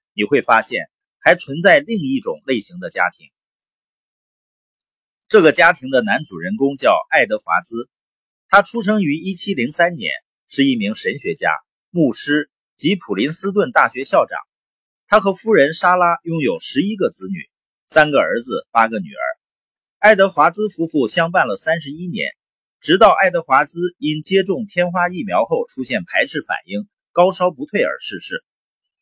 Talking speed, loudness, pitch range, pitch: 240 characters per minute, -17 LUFS, 155-215 Hz, 180 Hz